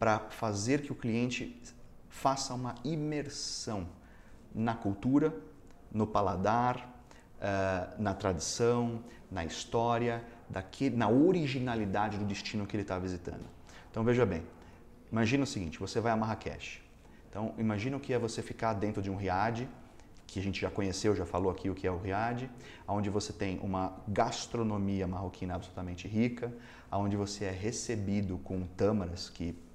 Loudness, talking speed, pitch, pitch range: -34 LUFS, 145 wpm, 105 Hz, 95-120 Hz